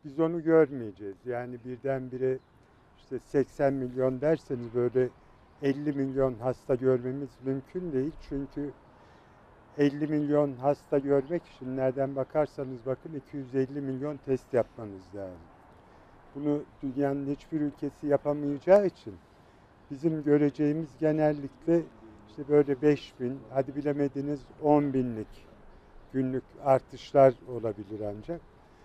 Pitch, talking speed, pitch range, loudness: 135 Hz, 105 wpm, 130-145 Hz, -29 LUFS